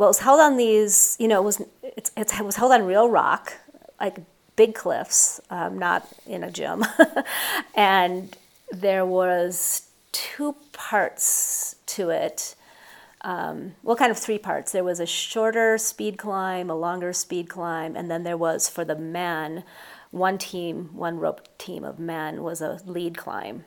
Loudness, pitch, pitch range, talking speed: -23 LUFS, 190 Hz, 175-220 Hz, 165 wpm